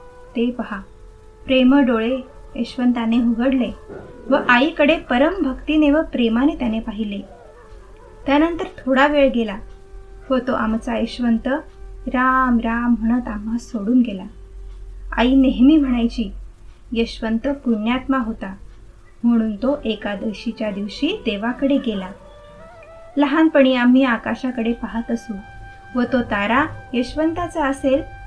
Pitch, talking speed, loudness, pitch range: 245 Hz, 100 wpm, -19 LUFS, 225-275 Hz